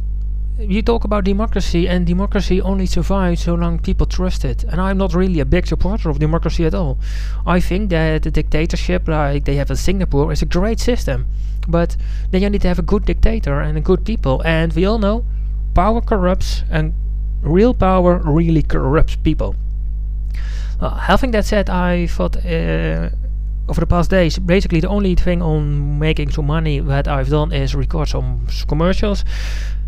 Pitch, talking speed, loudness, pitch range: 165 Hz, 180 wpm, -18 LUFS, 135-185 Hz